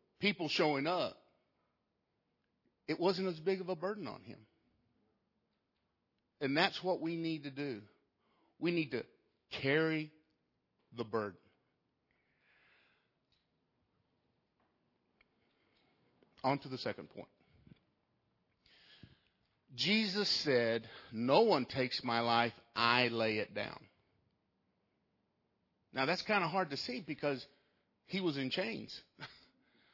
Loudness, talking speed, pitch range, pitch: -35 LUFS, 105 wpm, 120-180 Hz, 145 Hz